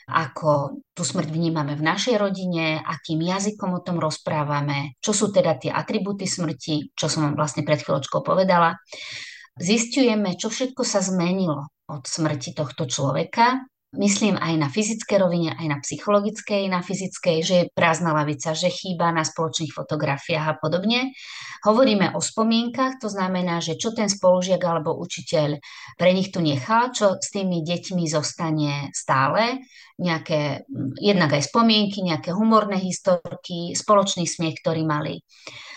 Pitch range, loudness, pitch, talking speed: 155-200 Hz, -22 LUFS, 175 Hz, 145 wpm